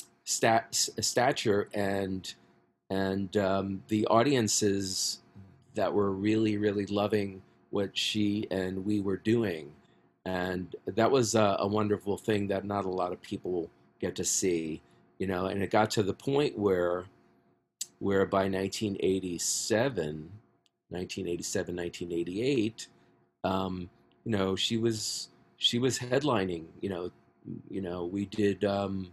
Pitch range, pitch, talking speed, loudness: 90-105 Hz, 95 Hz, 130 wpm, -30 LUFS